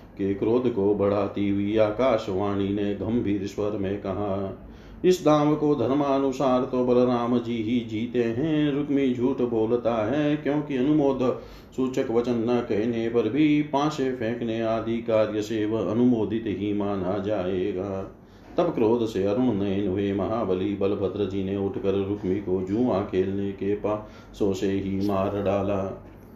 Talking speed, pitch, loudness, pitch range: 140 wpm, 110 Hz, -25 LUFS, 100-125 Hz